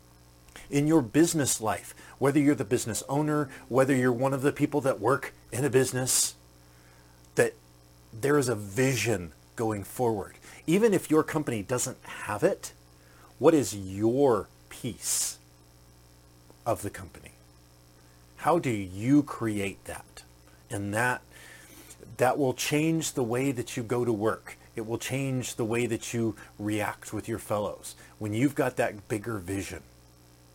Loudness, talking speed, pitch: -28 LUFS, 145 wpm, 110 Hz